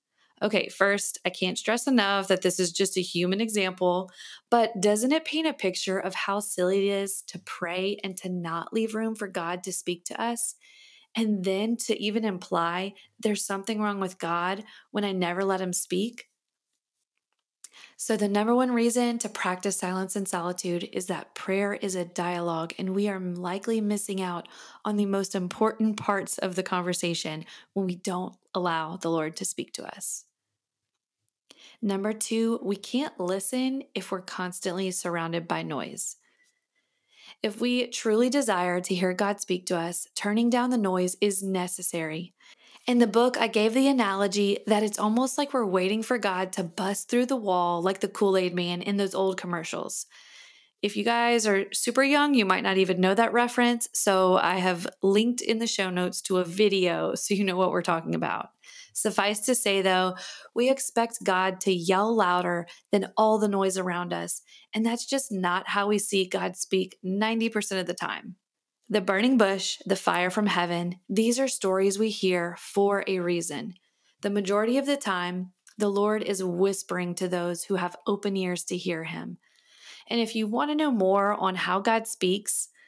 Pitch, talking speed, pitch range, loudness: 195 Hz, 185 wpm, 185-220 Hz, -27 LUFS